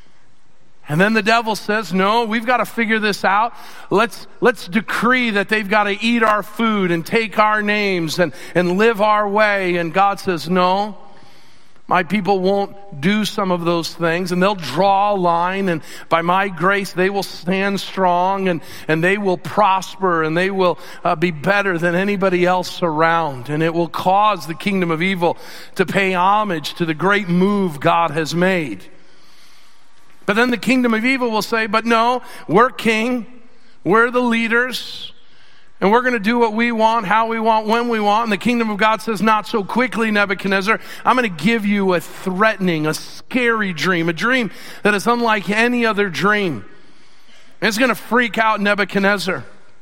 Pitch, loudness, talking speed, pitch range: 200 Hz, -17 LUFS, 185 wpm, 180-225 Hz